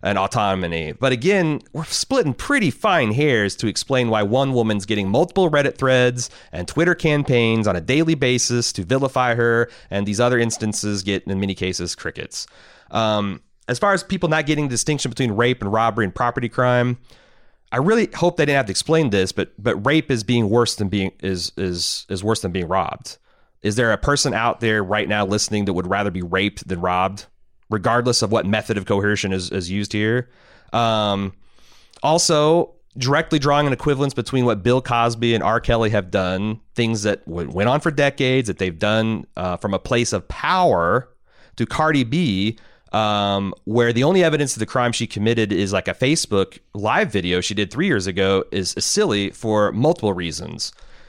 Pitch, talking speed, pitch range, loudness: 115 Hz, 190 wpm, 100-130 Hz, -20 LUFS